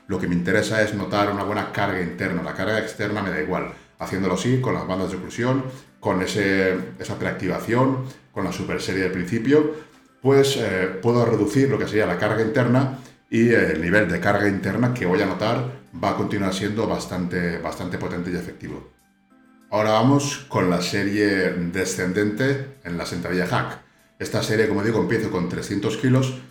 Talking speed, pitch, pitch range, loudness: 185 wpm, 105 Hz, 95-130 Hz, -22 LUFS